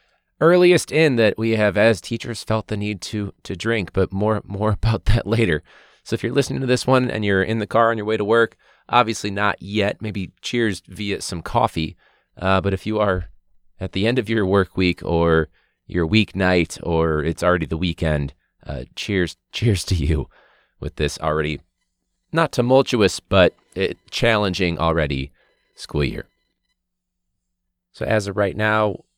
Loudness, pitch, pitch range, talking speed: -20 LUFS, 100 Hz, 90-115 Hz, 175 wpm